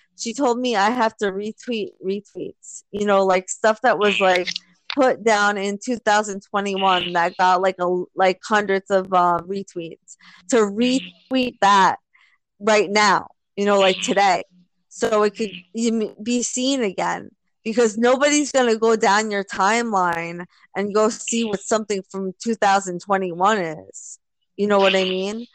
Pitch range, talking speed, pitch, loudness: 185-225 Hz, 150 wpm, 200 Hz, -20 LUFS